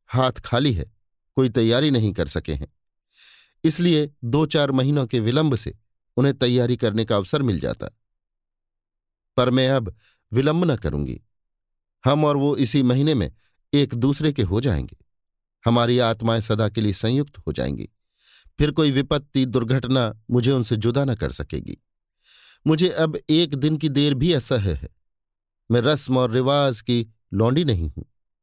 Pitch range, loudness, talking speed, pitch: 100-140 Hz, -21 LUFS, 160 wpm, 120 Hz